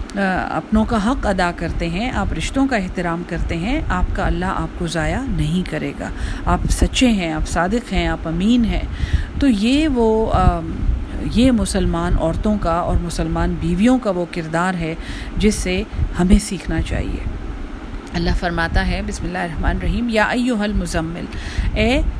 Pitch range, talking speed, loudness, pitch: 170-220 Hz, 160 wpm, -19 LUFS, 185 Hz